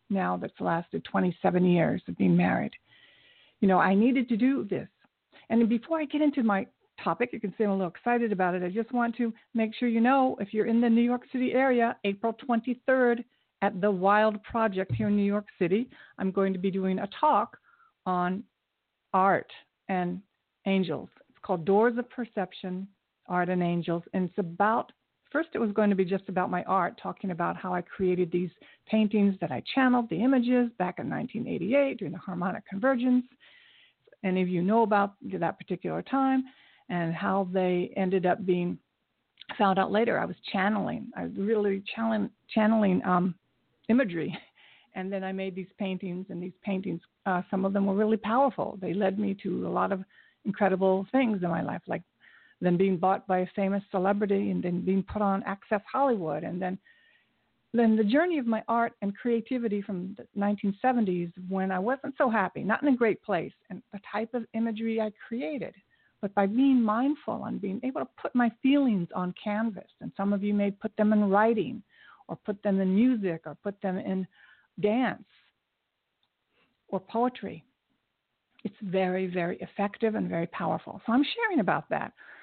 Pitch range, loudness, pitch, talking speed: 190-235 Hz, -28 LUFS, 205 Hz, 185 wpm